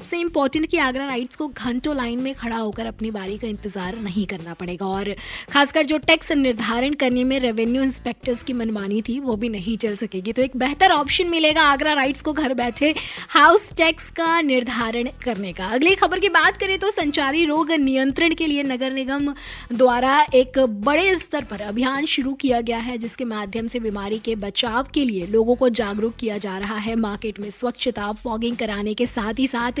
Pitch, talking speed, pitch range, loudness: 250 Hz, 195 wpm, 225-285 Hz, -21 LUFS